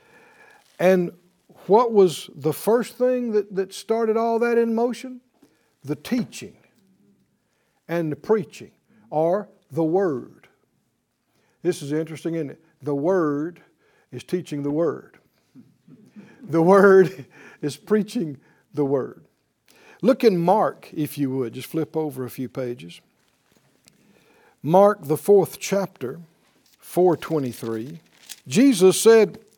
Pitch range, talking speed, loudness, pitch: 150-215 Hz, 115 wpm, -21 LUFS, 180 Hz